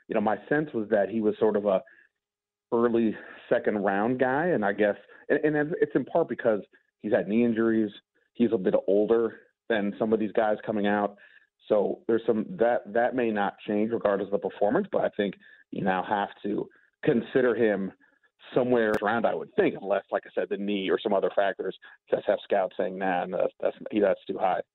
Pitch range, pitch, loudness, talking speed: 105-120 Hz, 110 Hz, -27 LUFS, 210 wpm